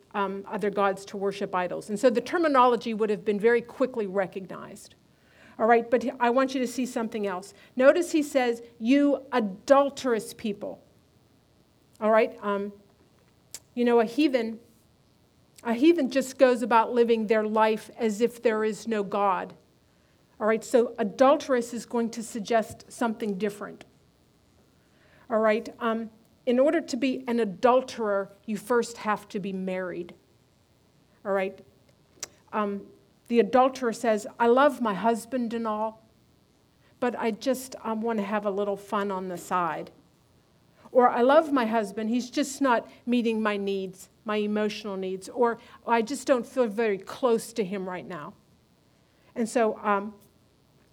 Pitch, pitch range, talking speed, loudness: 225 Hz, 205-245 Hz, 155 wpm, -26 LUFS